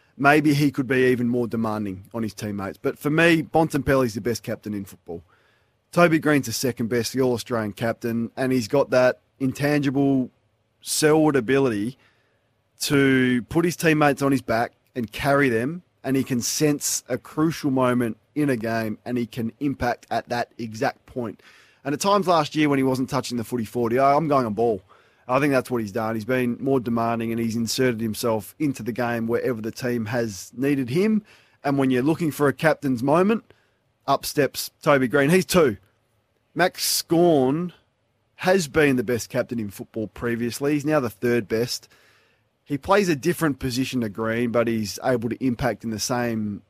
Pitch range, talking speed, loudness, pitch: 115-140 Hz, 190 wpm, -23 LUFS, 125 Hz